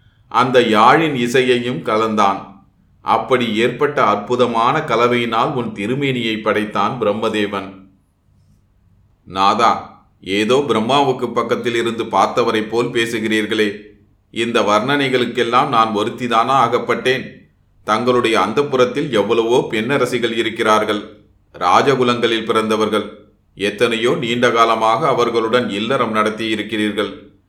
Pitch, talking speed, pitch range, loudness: 115 Hz, 85 wpm, 105-120 Hz, -16 LUFS